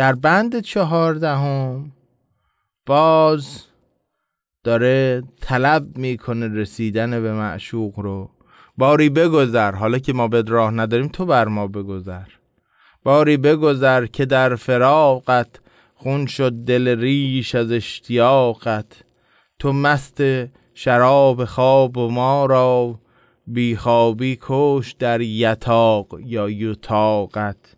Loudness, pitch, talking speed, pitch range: -18 LUFS, 125 Hz, 105 wpm, 115-135 Hz